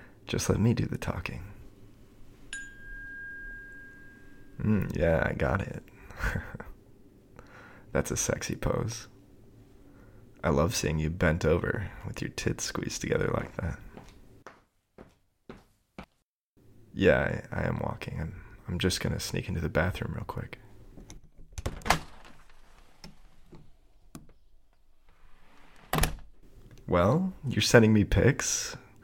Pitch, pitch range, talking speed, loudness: 105 Hz, 95-125 Hz, 100 wpm, -29 LUFS